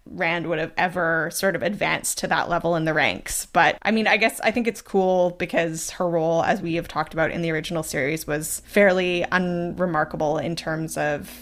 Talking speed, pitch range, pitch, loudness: 210 wpm, 160-180 Hz, 170 Hz, -22 LUFS